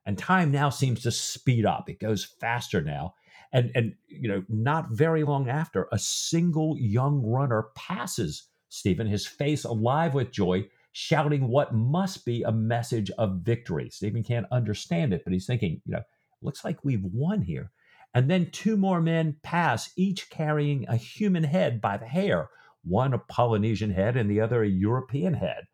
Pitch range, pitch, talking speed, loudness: 110-155 Hz, 125 Hz, 175 wpm, -27 LUFS